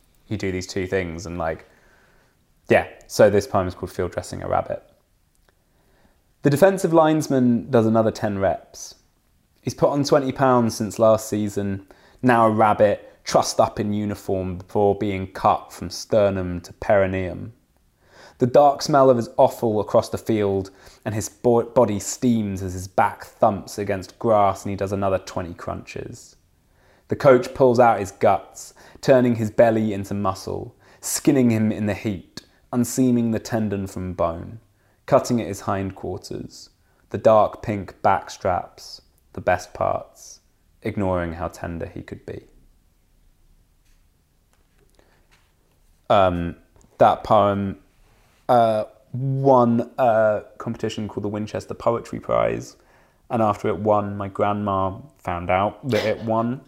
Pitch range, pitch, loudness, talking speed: 95-115 Hz, 105 Hz, -21 LUFS, 140 wpm